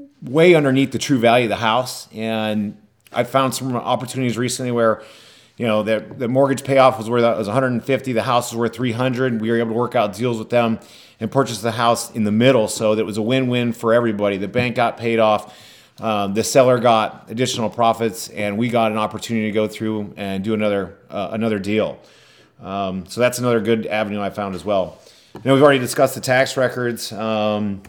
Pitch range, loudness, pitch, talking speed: 110-125 Hz, -19 LUFS, 115 Hz, 210 wpm